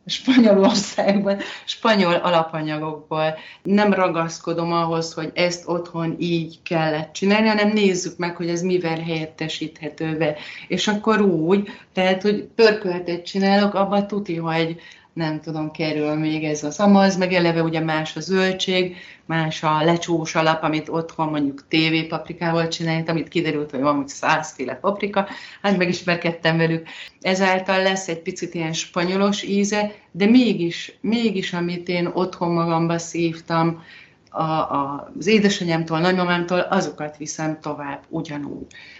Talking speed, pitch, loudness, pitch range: 135 wpm, 170 Hz, -21 LUFS, 160-190 Hz